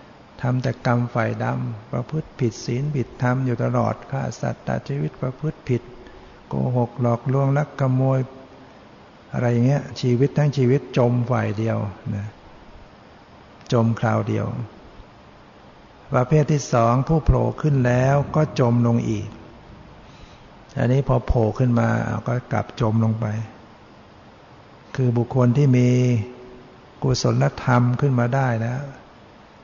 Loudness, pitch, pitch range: -22 LUFS, 125 Hz, 115-135 Hz